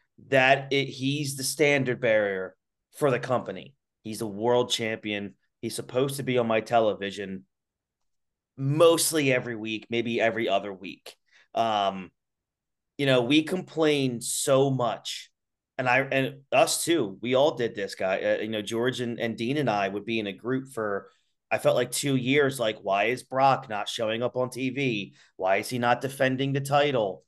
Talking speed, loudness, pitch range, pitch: 175 wpm, -26 LUFS, 110-135 Hz, 125 Hz